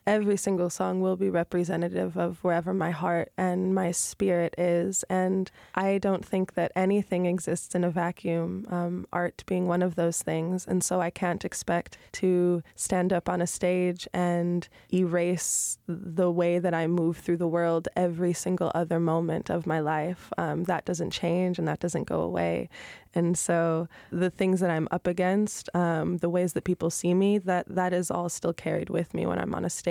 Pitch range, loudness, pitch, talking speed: 170-185 Hz, -28 LUFS, 175 Hz, 195 wpm